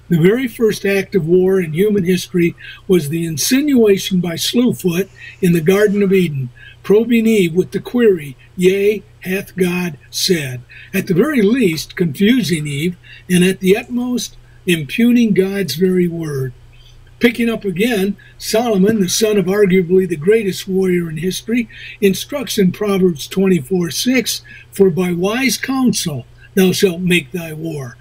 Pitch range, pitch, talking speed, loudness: 170-205 Hz, 185 Hz, 150 wpm, -15 LUFS